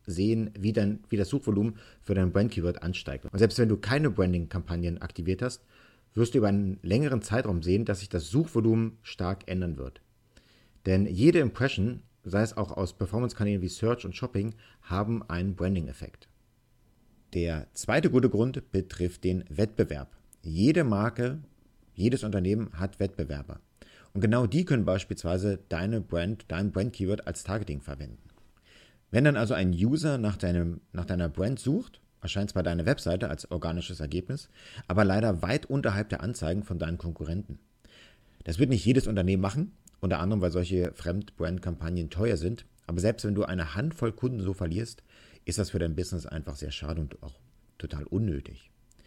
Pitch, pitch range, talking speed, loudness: 100 Hz, 90-115 Hz, 165 wpm, -29 LUFS